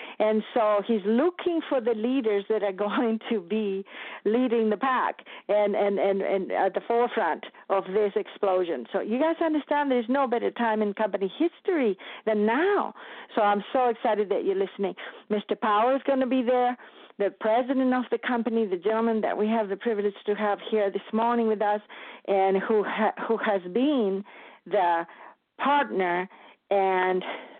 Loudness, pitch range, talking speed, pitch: -26 LUFS, 200-245 Hz, 175 wpm, 215 Hz